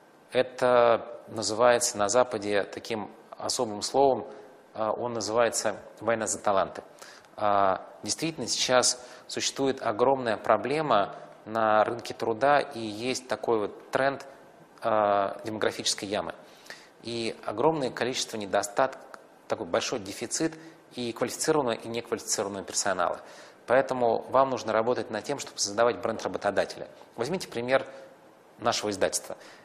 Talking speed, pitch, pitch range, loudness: 105 wpm, 120 Hz, 110-130 Hz, -28 LUFS